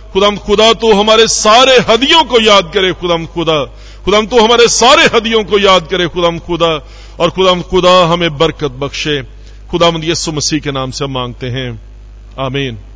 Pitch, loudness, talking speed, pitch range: 170 Hz, -10 LUFS, 175 wpm, 135-205 Hz